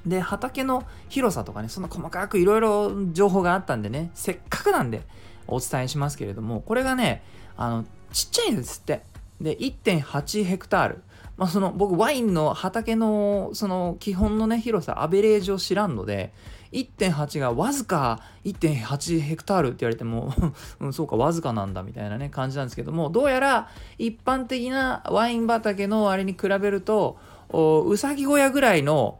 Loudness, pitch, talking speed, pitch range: -24 LUFS, 185 Hz, 340 characters per minute, 130-215 Hz